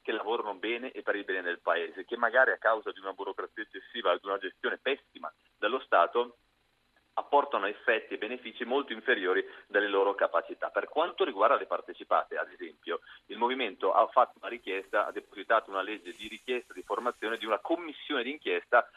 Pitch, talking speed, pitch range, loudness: 390 Hz, 180 wpm, 335-435 Hz, -31 LUFS